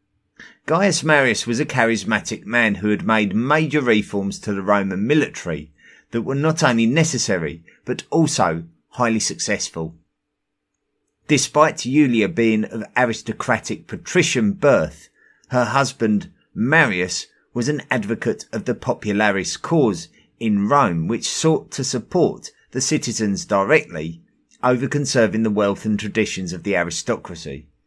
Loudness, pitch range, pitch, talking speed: -20 LUFS, 100-130 Hz, 110 Hz, 125 wpm